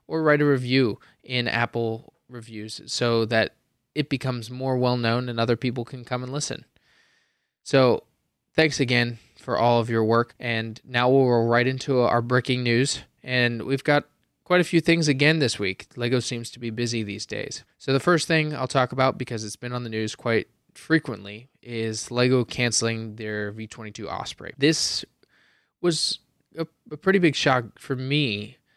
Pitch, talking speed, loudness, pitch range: 125 Hz, 180 wpm, -24 LUFS, 115-140 Hz